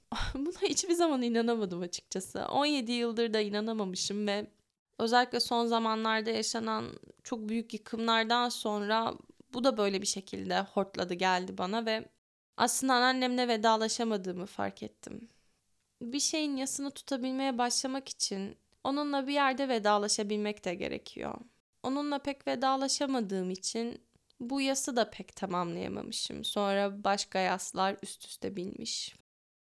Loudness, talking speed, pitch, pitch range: -32 LUFS, 120 wpm, 230 Hz, 205-265 Hz